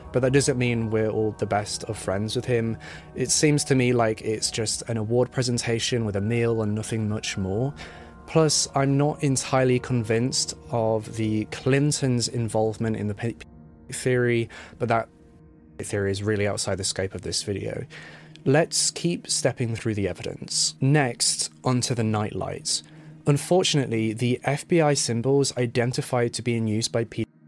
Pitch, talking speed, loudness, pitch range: 115 Hz, 165 wpm, -24 LUFS, 110-135 Hz